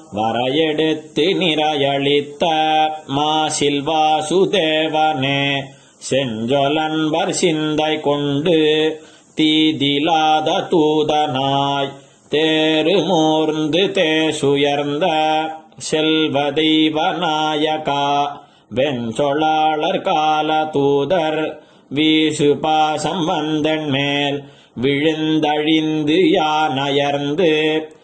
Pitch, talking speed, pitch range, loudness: 155 Hz, 45 wpm, 145-155 Hz, -17 LUFS